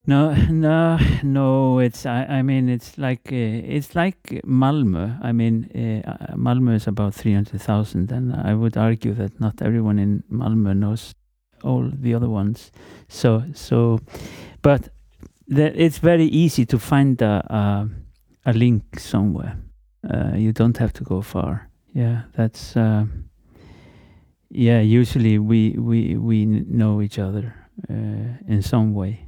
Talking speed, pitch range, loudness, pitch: 145 wpm, 105-125 Hz, -20 LUFS, 115 Hz